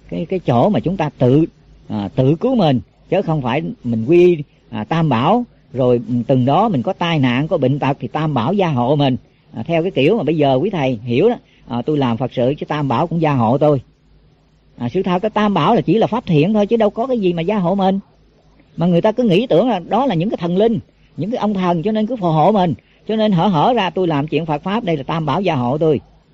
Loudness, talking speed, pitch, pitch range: -16 LUFS, 270 wpm, 160 Hz, 135-195 Hz